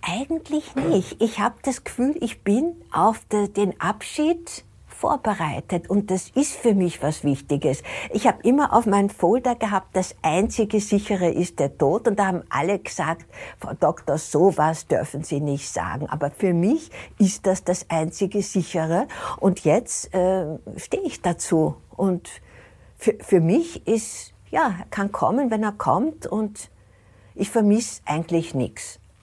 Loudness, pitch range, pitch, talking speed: -23 LUFS, 160-225 Hz, 195 Hz, 155 wpm